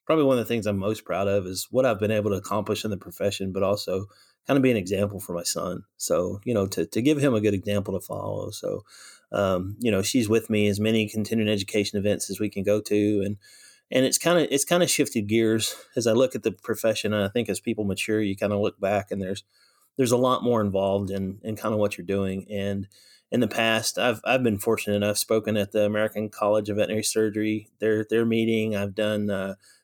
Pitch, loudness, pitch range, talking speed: 105 Hz, -25 LUFS, 100-110 Hz, 245 wpm